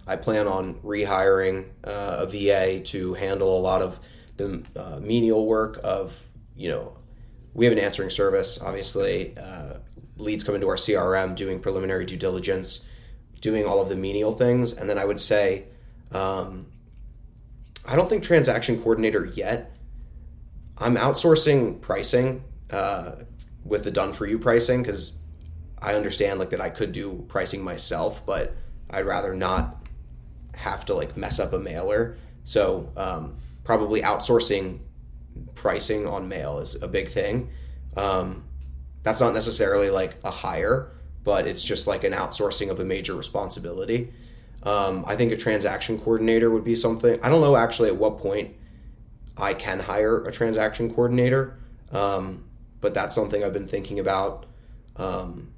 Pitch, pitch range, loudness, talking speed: 100 Hz, 95-115 Hz, -24 LUFS, 155 wpm